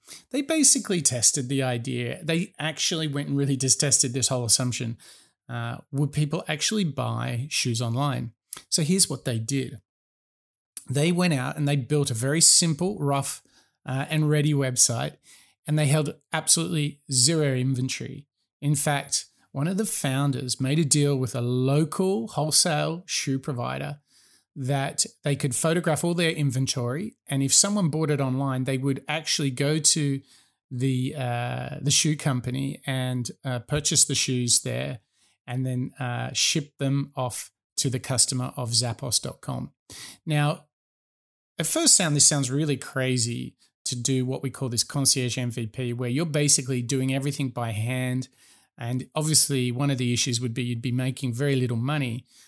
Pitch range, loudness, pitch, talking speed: 125-150 Hz, -23 LUFS, 135 Hz, 160 wpm